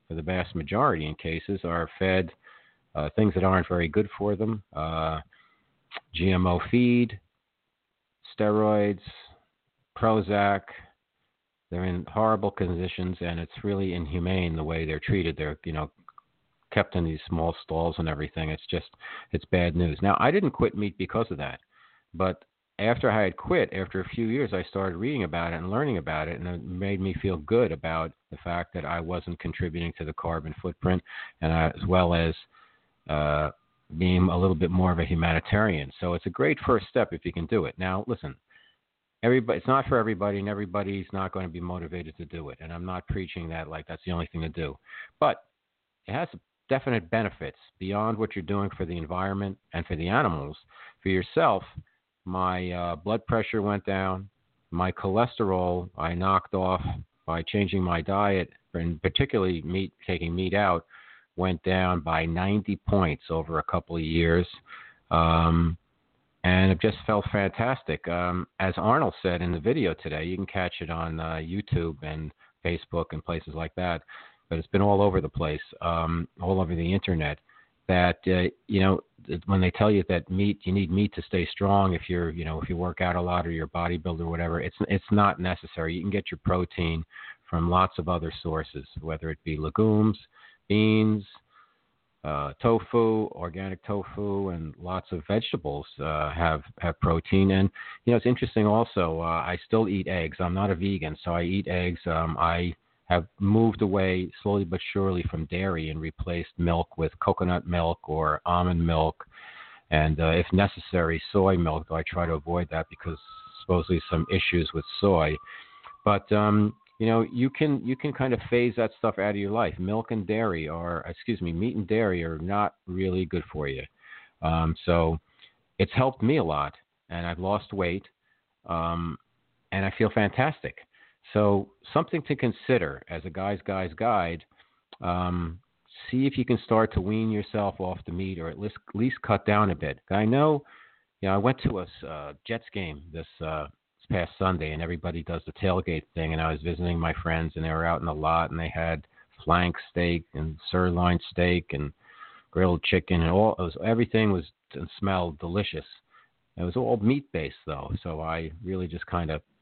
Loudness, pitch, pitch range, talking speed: -27 LUFS, 90 Hz, 85-100 Hz, 185 wpm